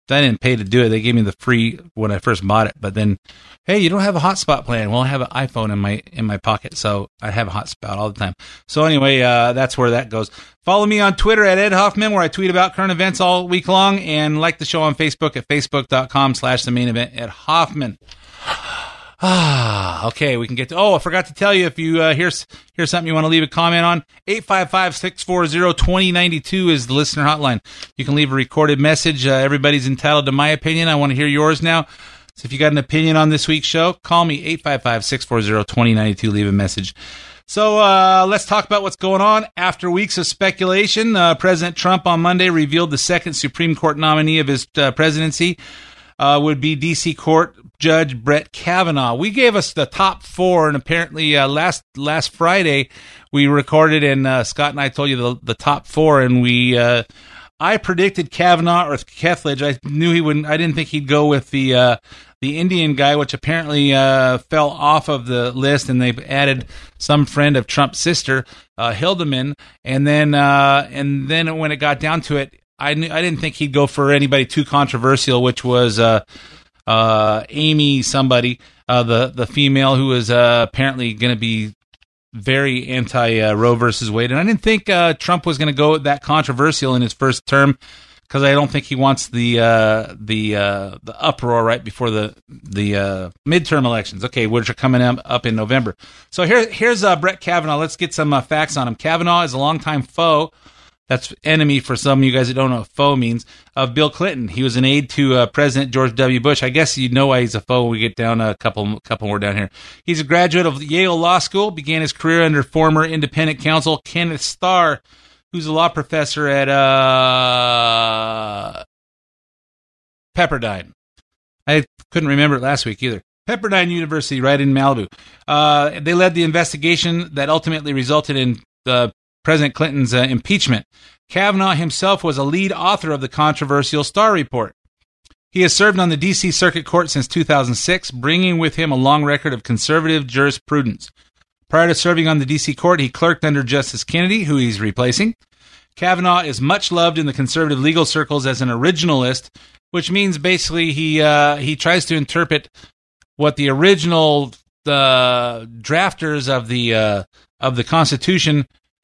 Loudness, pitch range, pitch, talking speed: -16 LUFS, 125-165 Hz, 145 Hz, 195 wpm